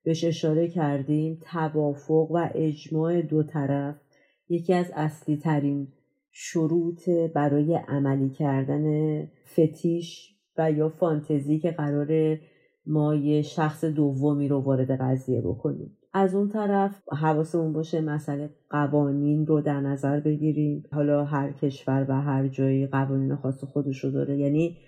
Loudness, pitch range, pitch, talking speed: -26 LUFS, 140-160 Hz, 150 Hz, 130 wpm